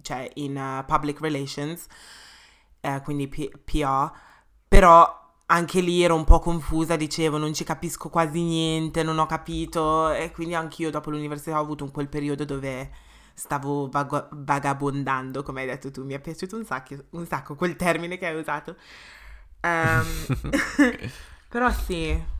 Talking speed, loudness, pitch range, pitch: 160 wpm, -25 LUFS, 140-165 Hz, 155 Hz